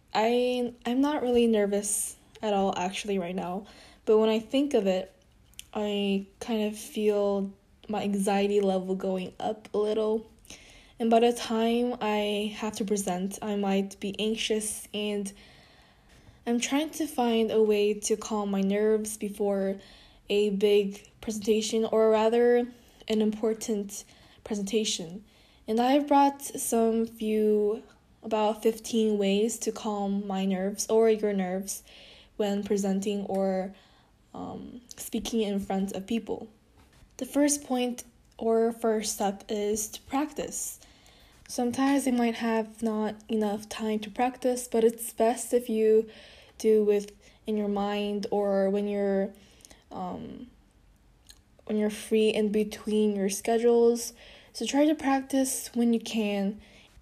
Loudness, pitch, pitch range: -28 LUFS, 215 Hz, 205-230 Hz